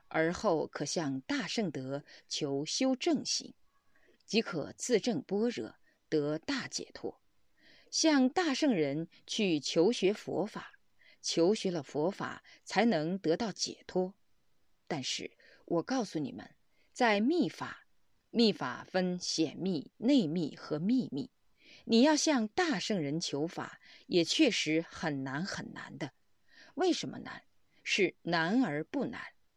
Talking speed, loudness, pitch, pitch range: 175 characters per minute, -32 LUFS, 190 Hz, 160-255 Hz